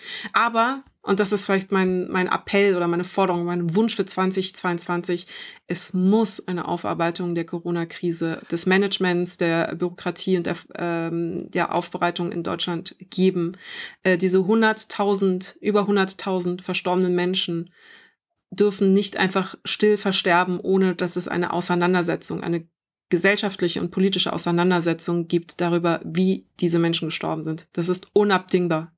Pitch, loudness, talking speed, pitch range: 180 Hz, -22 LUFS, 135 wpm, 175-190 Hz